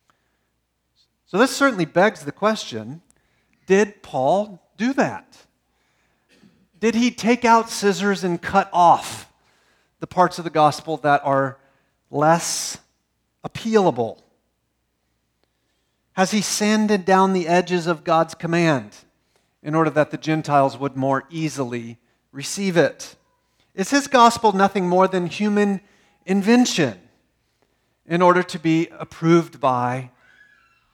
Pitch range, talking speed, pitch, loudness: 140-200 Hz, 115 wpm, 170 Hz, -20 LUFS